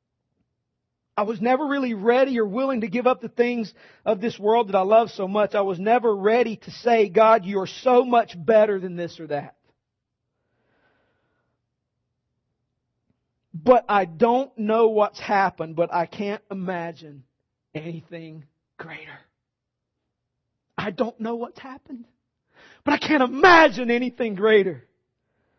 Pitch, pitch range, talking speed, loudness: 205 Hz, 150-235 Hz, 140 wpm, -21 LUFS